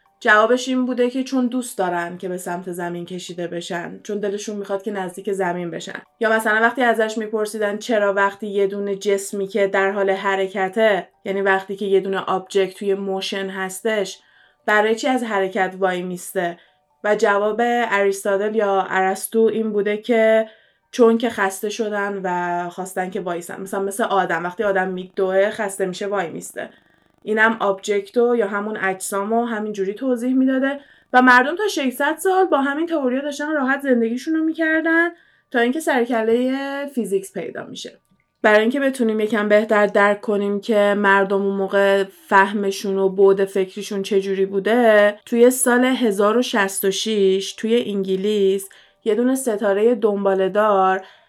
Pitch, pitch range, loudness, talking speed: 205 Hz, 195-230 Hz, -19 LUFS, 150 wpm